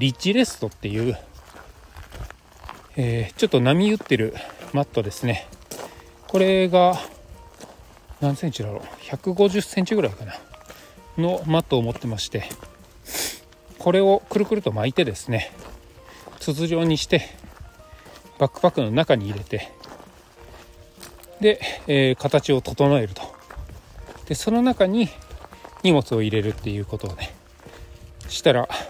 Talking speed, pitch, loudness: 245 characters per minute, 130 Hz, -22 LUFS